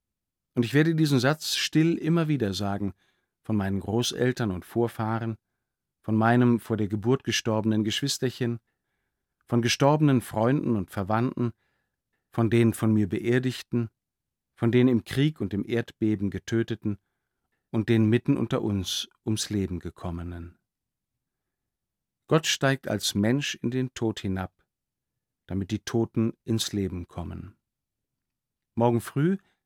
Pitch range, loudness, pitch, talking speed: 105-125 Hz, -26 LUFS, 115 Hz, 125 wpm